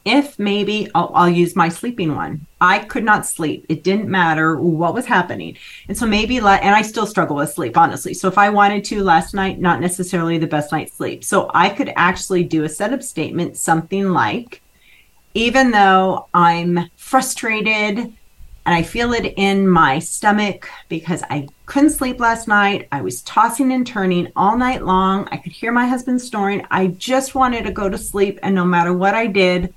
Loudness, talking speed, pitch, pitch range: -17 LUFS, 195 wpm, 195 Hz, 175-215 Hz